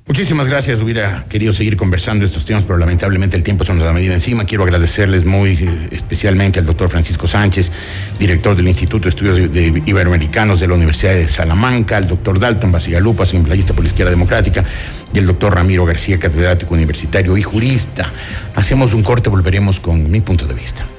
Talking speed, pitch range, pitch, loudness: 185 wpm, 90-105 Hz, 95 Hz, -13 LUFS